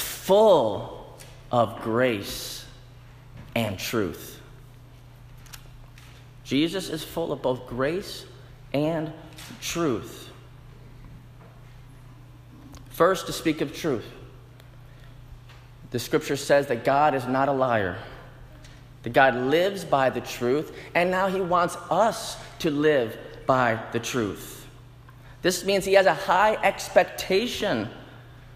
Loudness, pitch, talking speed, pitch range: -24 LUFS, 130 Hz, 105 wpm, 125-150 Hz